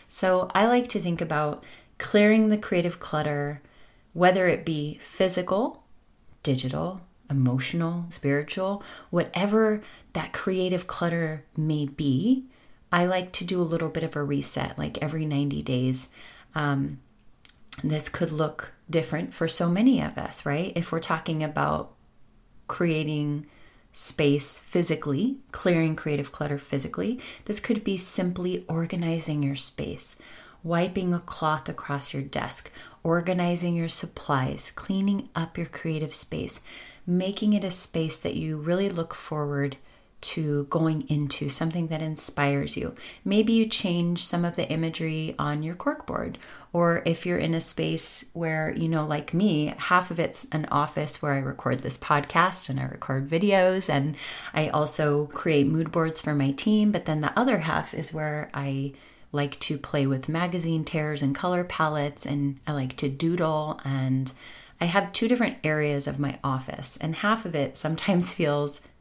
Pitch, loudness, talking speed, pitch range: 160 Hz, -26 LUFS, 155 wpm, 145-180 Hz